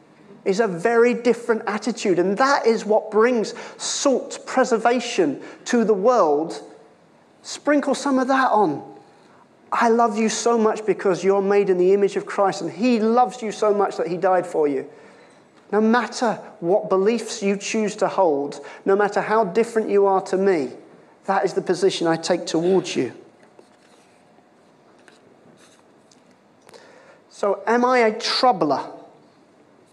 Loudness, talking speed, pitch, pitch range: -20 LUFS, 145 wpm, 220 Hz, 195-235 Hz